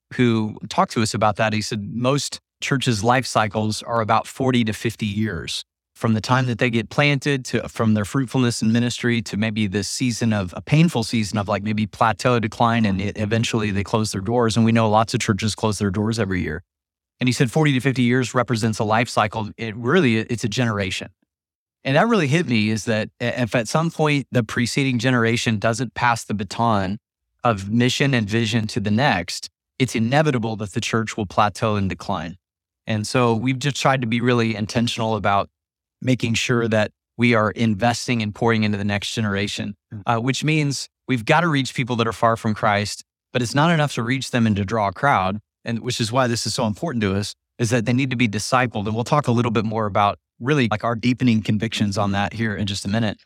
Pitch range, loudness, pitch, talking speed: 105-125 Hz, -21 LUFS, 115 Hz, 220 wpm